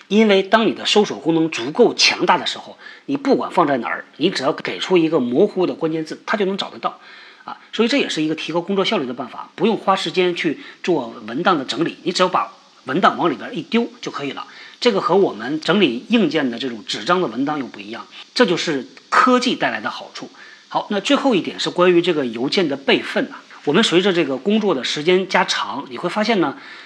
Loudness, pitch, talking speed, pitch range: -18 LUFS, 205 Hz, 340 characters per minute, 175-250 Hz